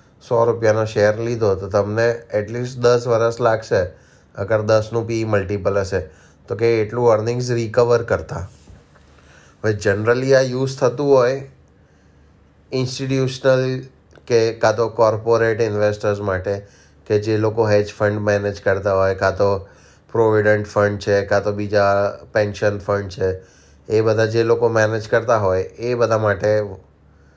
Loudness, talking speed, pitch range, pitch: -19 LUFS, 140 wpm, 100-115 Hz, 105 Hz